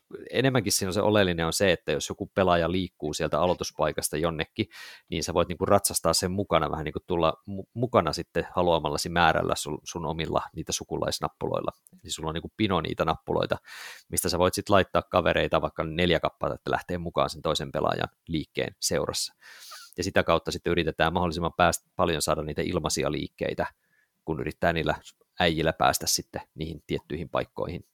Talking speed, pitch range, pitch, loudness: 175 wpm, 80-95 Hz, 85 Hz, -27 LUFS